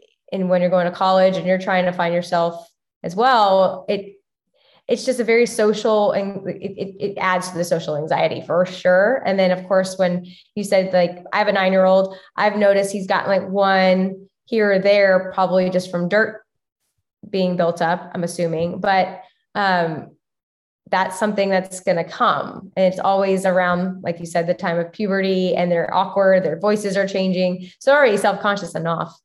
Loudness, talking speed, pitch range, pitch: -19 LUFS, 195 wpm, 180-200 Hz, 190 Hz